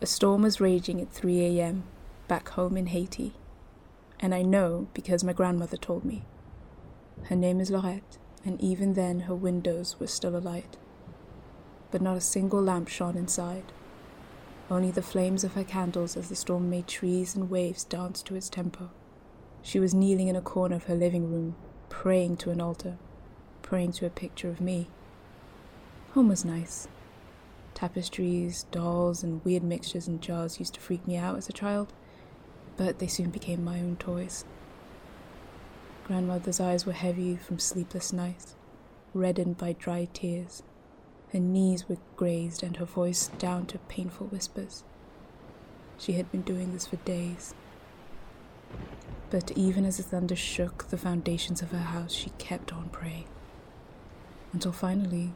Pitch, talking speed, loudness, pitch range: 180 Hz, 160 wpm, -30 LUFS, 175-185 Hz